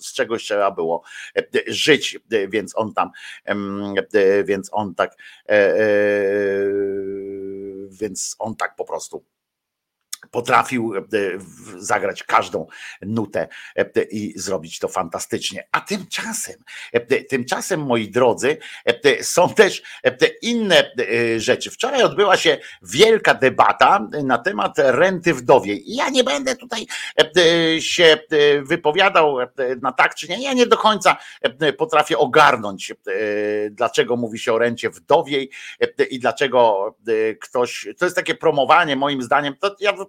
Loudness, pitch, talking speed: -18 LUFS, 170 Hz, 120 wpm